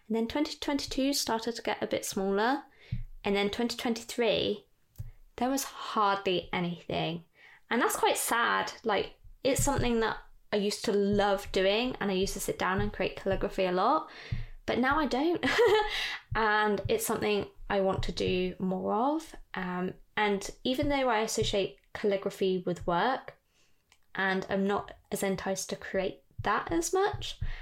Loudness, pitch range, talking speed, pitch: -30 LUFS, 195-245 Hz, 155 wpm, 205 Hz